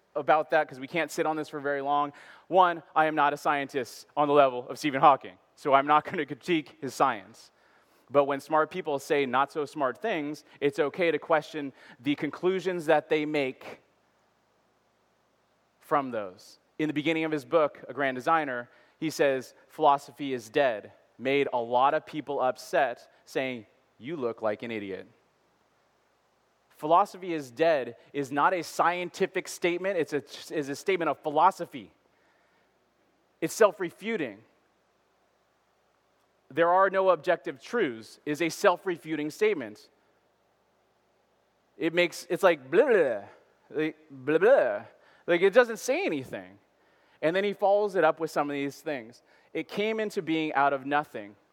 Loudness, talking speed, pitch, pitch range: -27 LUFS, 155 wpm, 155 Hz, 140-170 Hz